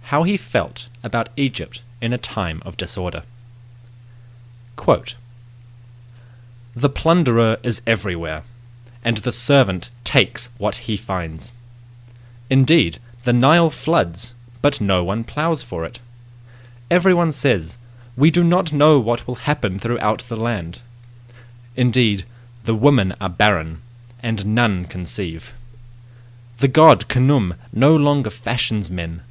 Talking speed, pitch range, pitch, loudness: 120 wpm, 110-125 Hz, 120 Hz, -19 LUFS